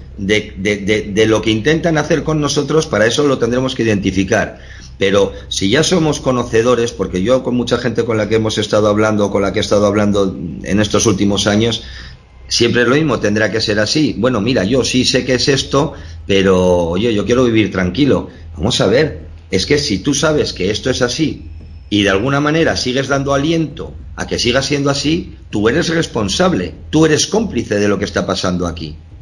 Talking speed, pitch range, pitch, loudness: 205 wpm, 100-140 Hz, 110 Hz, -14 LUFS